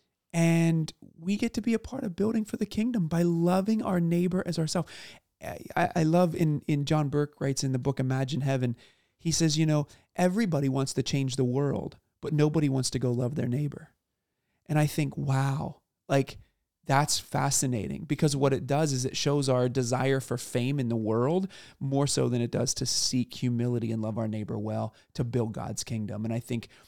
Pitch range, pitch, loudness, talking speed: 125-165 Hz, 140 Hz, -28 LUFS, 200 wpm